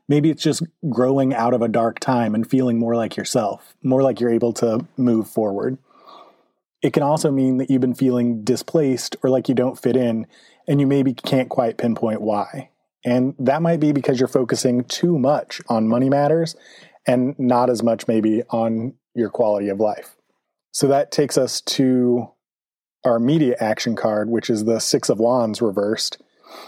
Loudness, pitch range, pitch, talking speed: -20 LUFS, 115-135 Hz, 125 Hz, 180 wpm